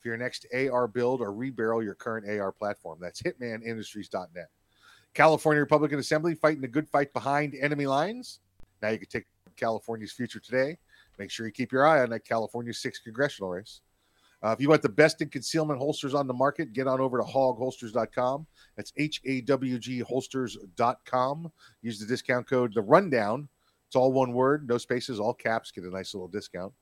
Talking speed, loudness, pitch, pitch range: 180 wpm, -28 LUFS, 125 Hz, 115-140 Hz